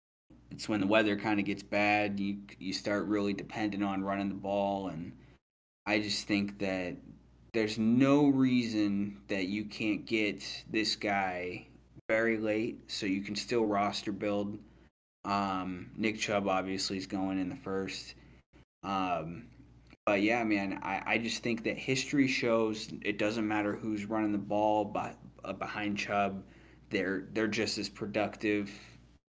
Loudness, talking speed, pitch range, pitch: -32 LUFS, 155 wpm, 100-110 Hz, 105 Hz